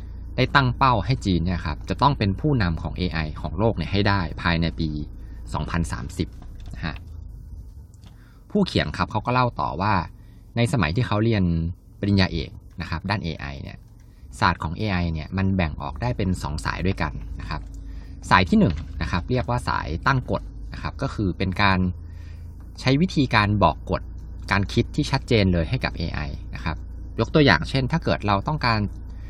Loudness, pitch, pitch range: -23 LUFS, 95 Hz, 85-110 Hz